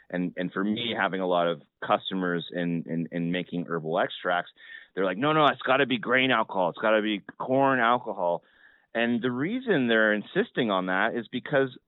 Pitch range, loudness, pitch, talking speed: 90-125 Hz, -26 LUFS, 110 Hz, 200 wpm